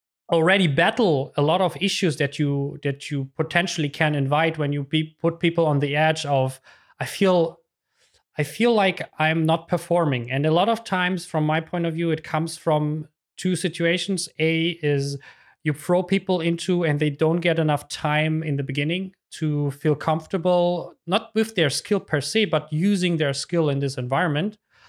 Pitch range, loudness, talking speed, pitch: 150-180 Hz, -23 LUFS, 185 wpm, 160 Hz